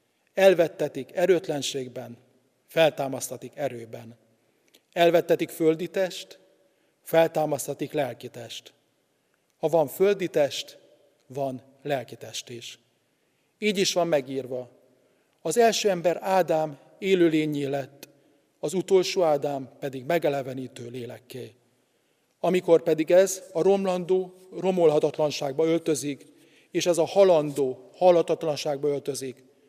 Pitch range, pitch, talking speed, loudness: 135-175 Hz, 150 Hz, 95 wpm, -25 LUFS